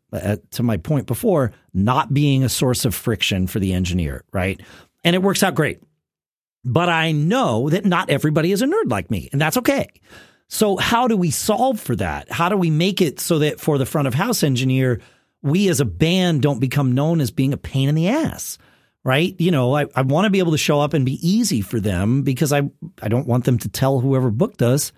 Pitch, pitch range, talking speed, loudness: 140 Hz, 120-165 Hz, 230 wpm, -19 LUFS